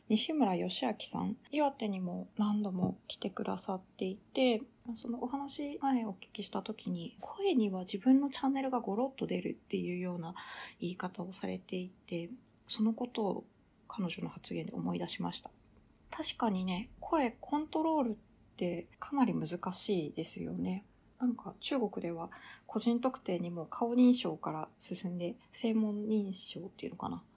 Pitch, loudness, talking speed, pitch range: 215 Hz, -36 LUFS, 285 characters per minute, 185-250 Hz